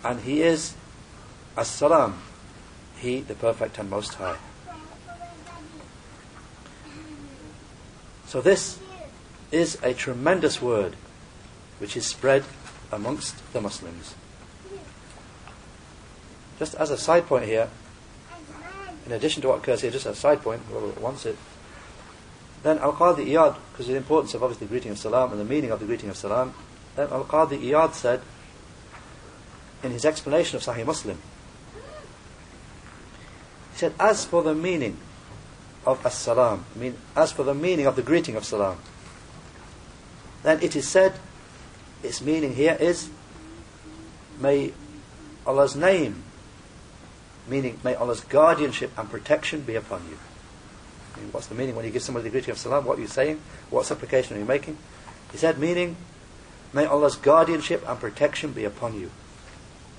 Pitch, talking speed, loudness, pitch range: 135 Hz, 145 wpm, -24 LUFS, 115-160 Hz